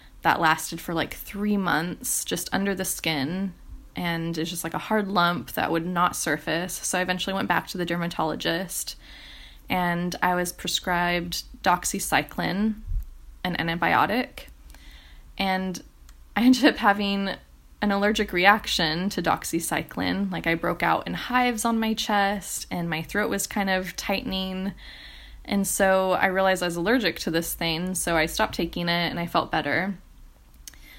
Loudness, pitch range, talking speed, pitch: -25 LUFS, 165-195 Hz, 155 wpm, 175 Hz